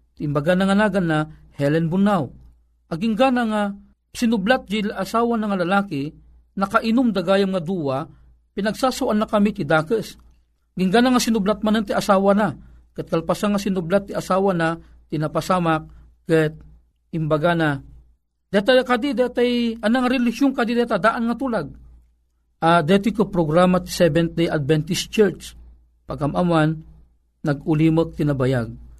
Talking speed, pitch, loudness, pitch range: 130 wpm, 180 Hz, -20 LUFS, 150-215 Hz